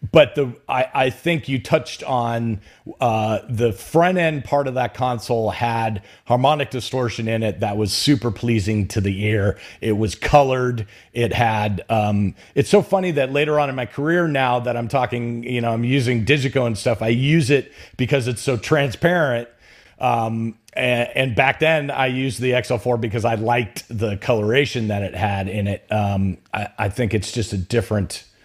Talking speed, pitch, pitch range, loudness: 185 wpm, 120 Hz, 110-135 Hz, -20 LUFS